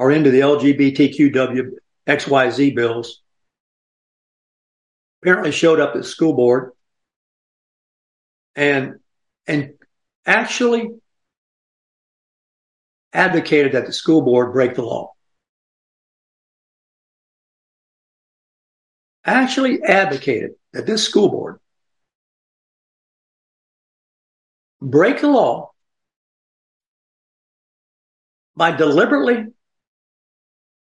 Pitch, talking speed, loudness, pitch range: 145 Hz, 70 wpm, -16 LUFS, 130-180 Hz